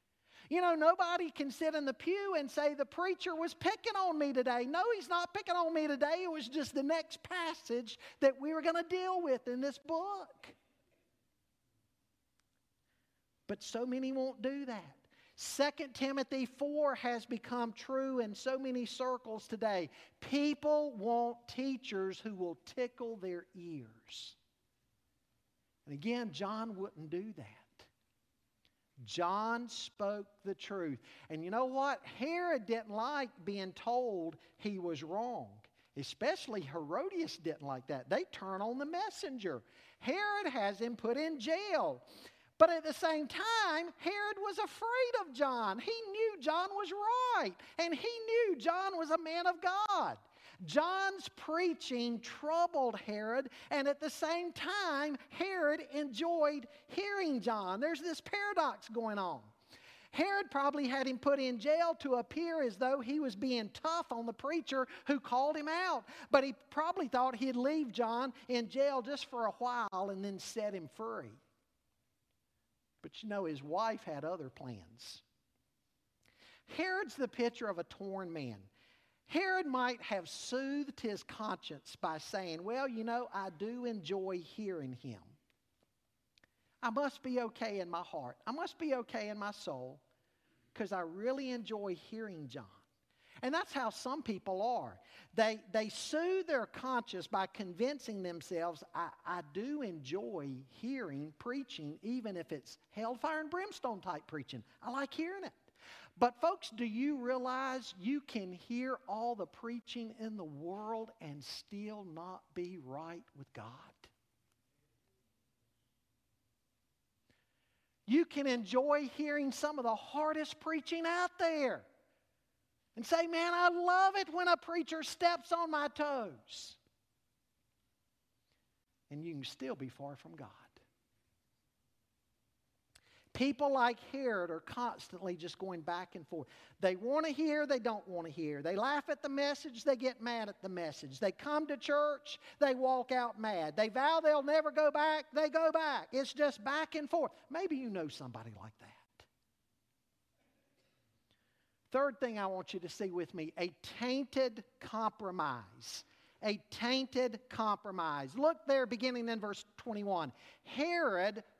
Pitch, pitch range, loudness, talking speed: 245 Hz, 185-300 Hz, -37 LUFS, 150 wpm